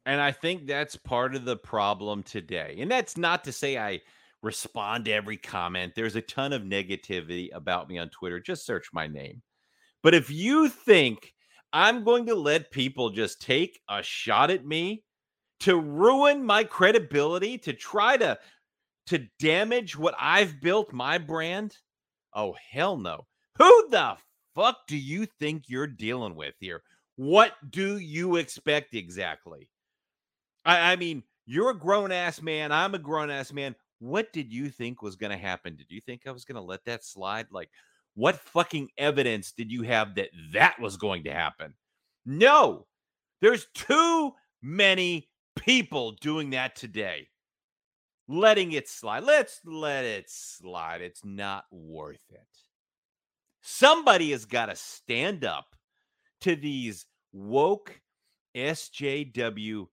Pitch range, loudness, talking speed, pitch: 110-180 Hz, -26 LUFS, 150 wpm, 145 Hz